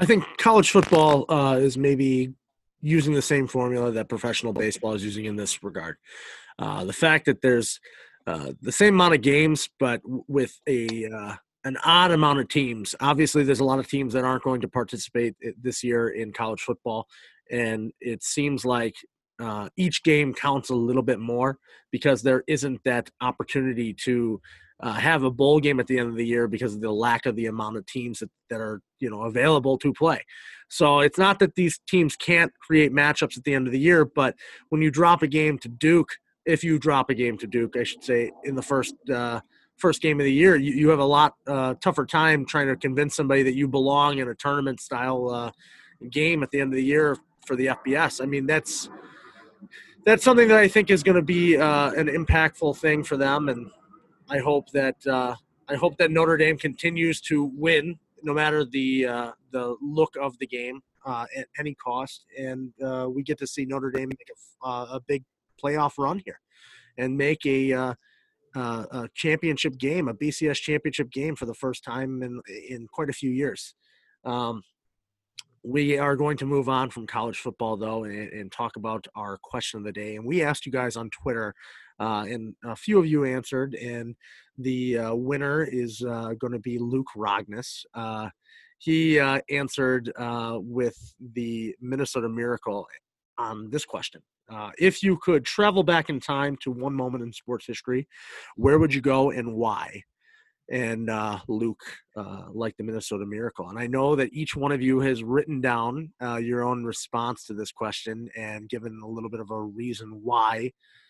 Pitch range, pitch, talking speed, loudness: 120-150 Hz, 130 Hz, 200 wpm, -24 LUFS